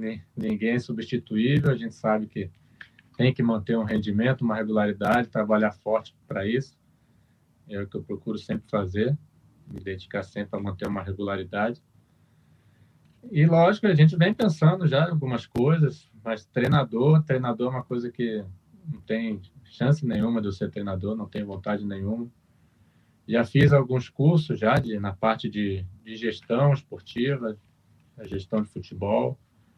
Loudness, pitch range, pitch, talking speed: -25 LUFS, 105-130 Hz, 115 Hz, 155 wpm